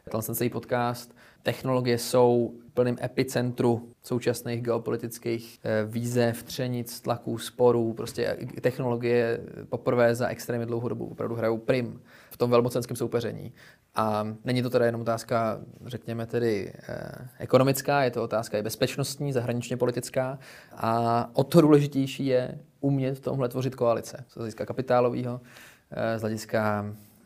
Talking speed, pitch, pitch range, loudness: 135 wpm, 120 Hz, 115-125 Hz, -27 LUFS